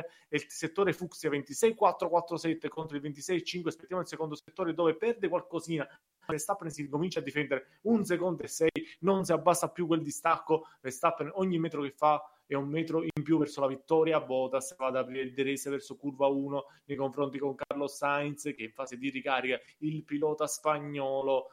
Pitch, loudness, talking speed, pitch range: 150 Hz, -32 LUFS, 185 wpm, 140-165 Hz